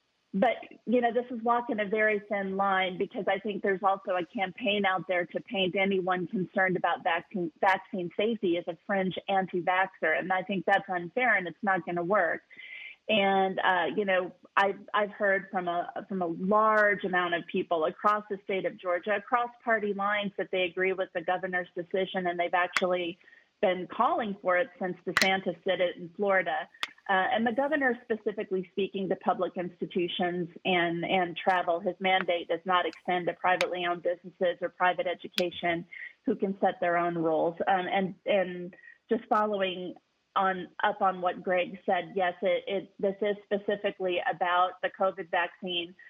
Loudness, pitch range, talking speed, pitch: -29 LUFS, 180-205 Hz, 175 wpm, 190 Hz